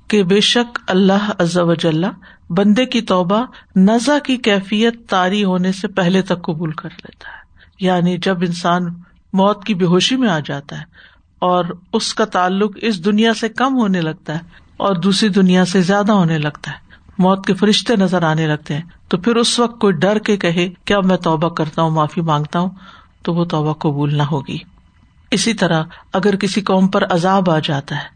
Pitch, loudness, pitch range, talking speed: 190 Hz, -16 LUFS, 170-210 Hz, 195 wpm